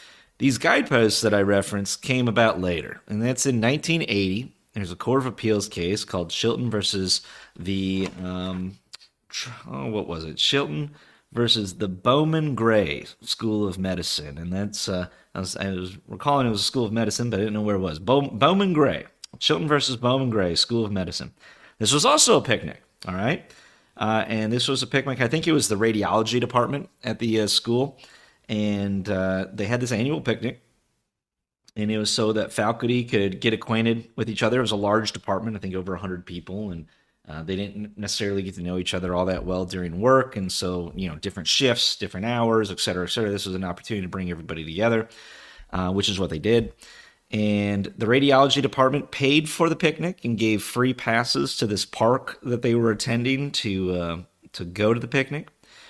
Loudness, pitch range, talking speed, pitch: -23 LUFS, 95-120 Hz, 200 wpm, 110 Hz